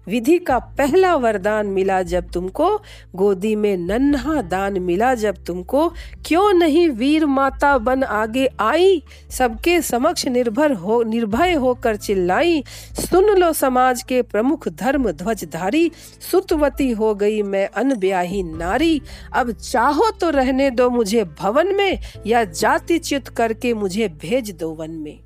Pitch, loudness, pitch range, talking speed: 250 Hz, -18 LUFS, 205-305 Hz, 140 wpm